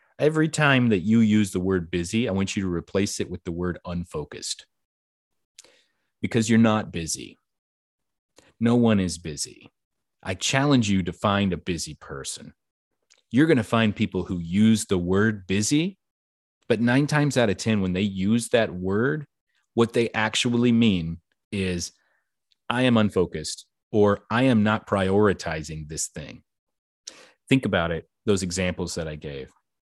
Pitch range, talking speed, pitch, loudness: 90-115 Hz, 155 wpm, 100 Hz, -24 LUFS